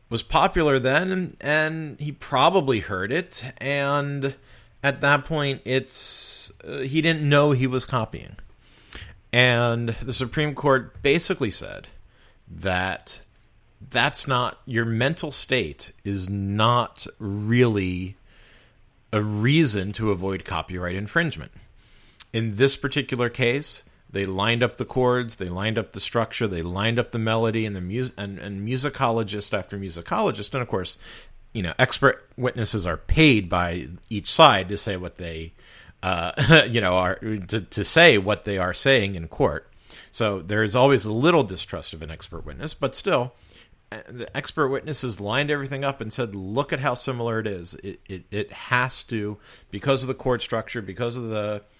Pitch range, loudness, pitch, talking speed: 100-130 Hz, -23 LUFS, 115 Hz, 160 wpm